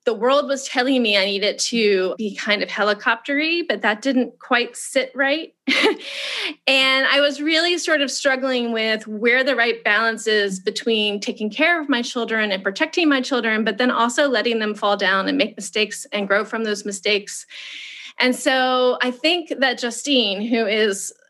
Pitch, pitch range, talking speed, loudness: 245 Hz, 215-275 Hz, 180 wpm, -19 LUFS